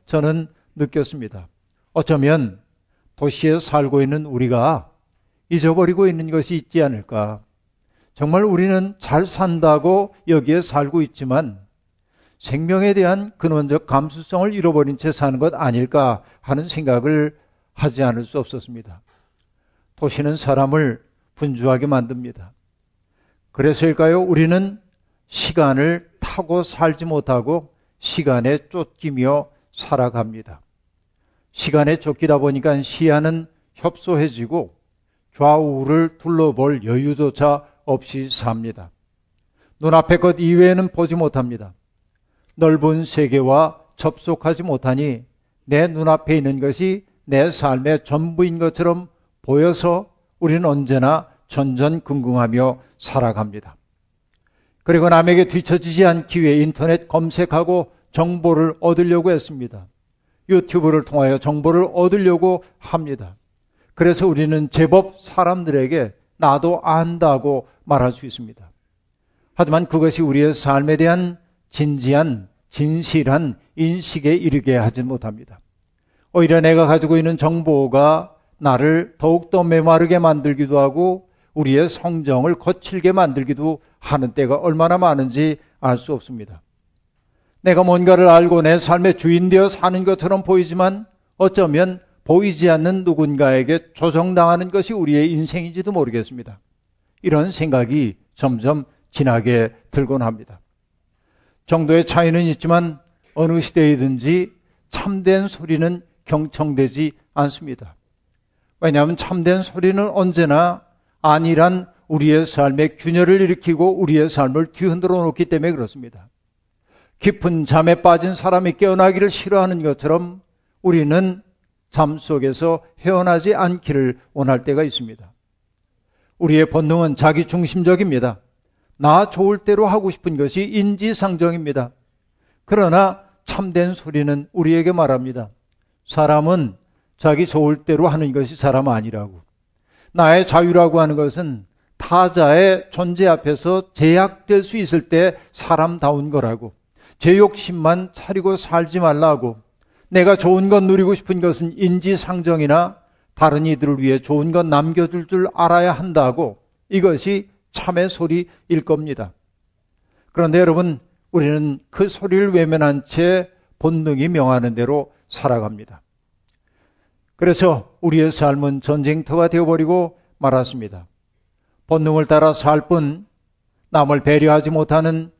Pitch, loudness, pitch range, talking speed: 155 Hz, -17 LUFS, 135-175 Hz, 275 characters per minute